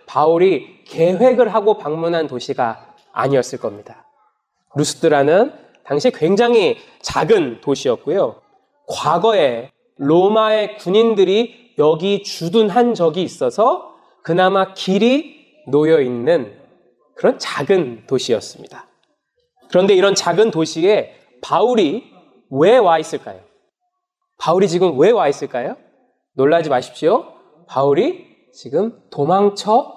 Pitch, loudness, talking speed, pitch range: 200 Hz, -16 LUFS, 245 characters per minute, 165-250 Hz